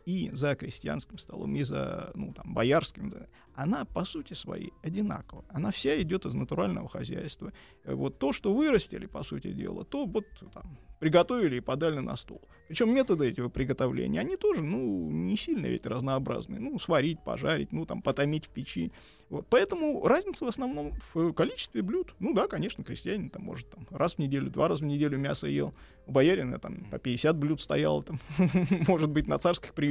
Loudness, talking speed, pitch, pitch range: -31 LUFS, 180 wpm, 160 Hz, 140-200 Hz